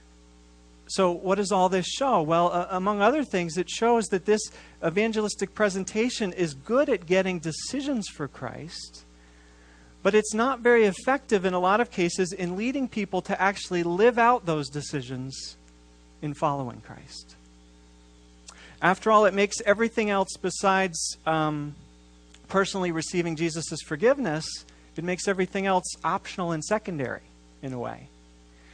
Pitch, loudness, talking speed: 180 Hz, -26 LUFS, 140 wpm